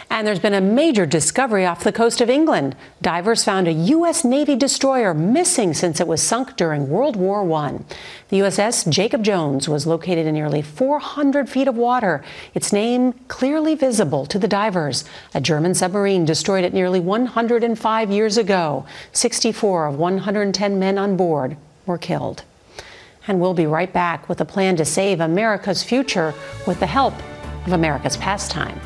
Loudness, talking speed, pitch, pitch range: -19 LUFS, 165 wpm, 190 Hz, 165-230 Hz